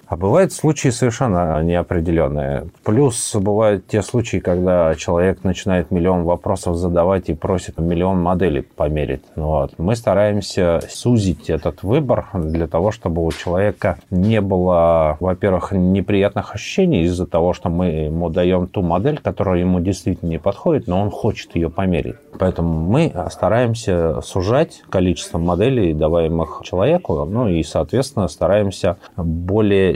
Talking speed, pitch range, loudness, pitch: 135 wpm, 85-105 Hz, -18 LUFS, 90 Hz